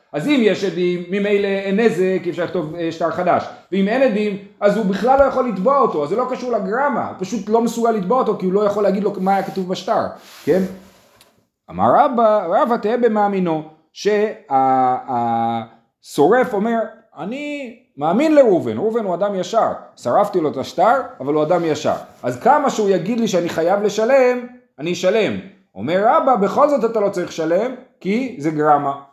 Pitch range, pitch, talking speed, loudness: 175-235 Hz, 205 Hz, 180 wpm, -18 LUFS